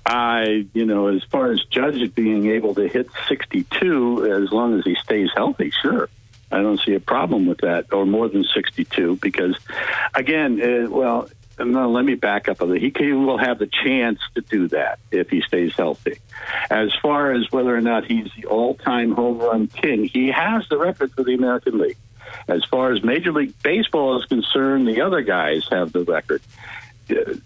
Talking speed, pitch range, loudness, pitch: 190 wpm, 110-135 Hz, -20 LUFS, 120 Hz